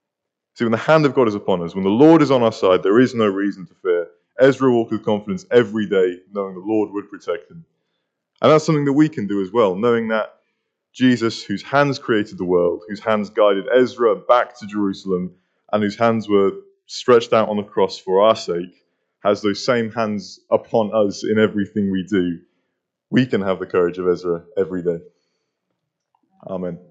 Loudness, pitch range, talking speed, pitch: -18 LUFS, 95-120 Hz, 200 wpm, 105 Hz